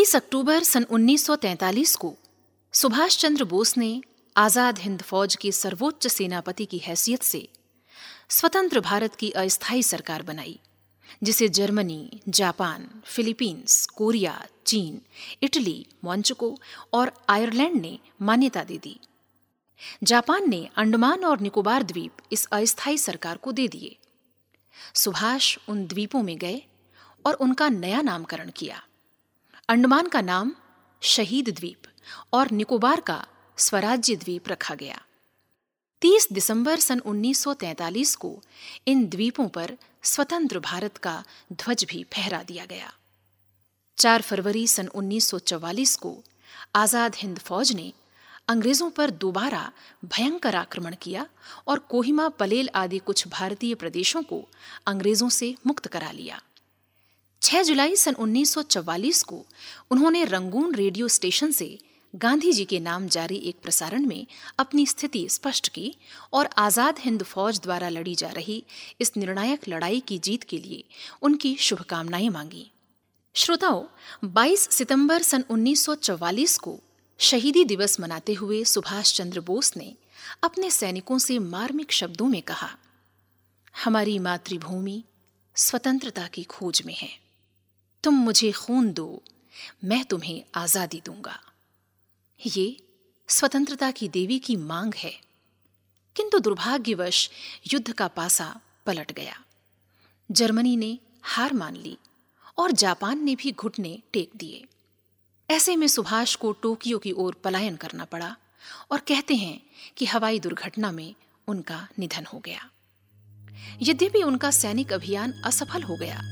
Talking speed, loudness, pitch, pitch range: 125 wpm, -24 LUFS, 215 Hz, 180-265 Hz